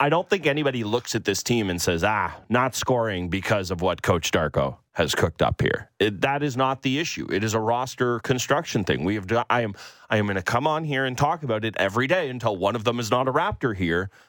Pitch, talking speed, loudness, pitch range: 120 Hz, 250 wpm, -24 LUFS, 105-135 Hz